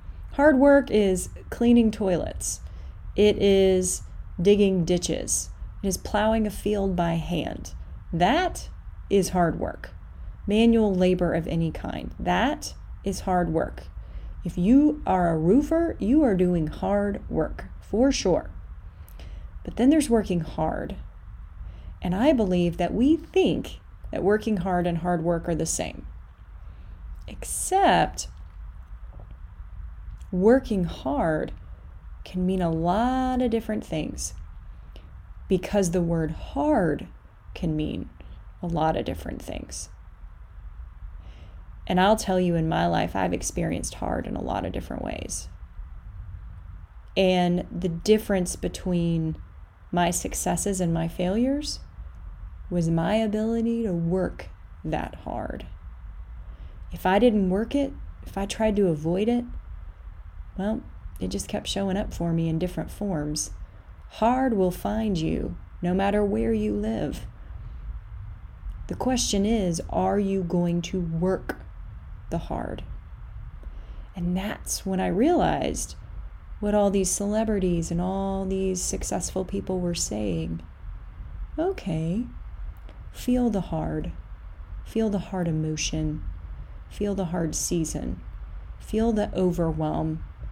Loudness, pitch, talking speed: -25 LUFS, 170 Hz, 125 wpm